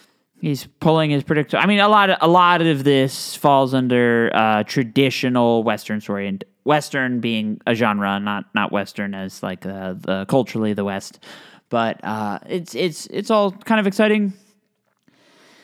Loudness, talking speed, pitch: -19 LUFS, 165 wpm, 135 Hz